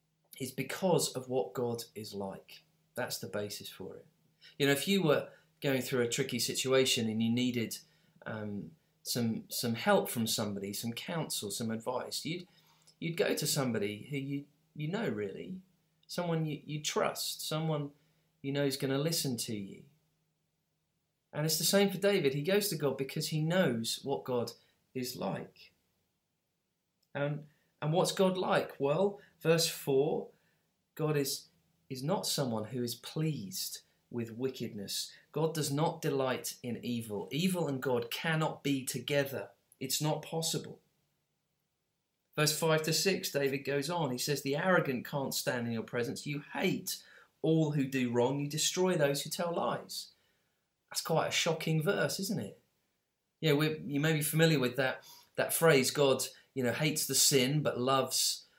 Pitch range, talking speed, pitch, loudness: 130-160 Hz, 165 wpm, 145 Hz, -33 LUFS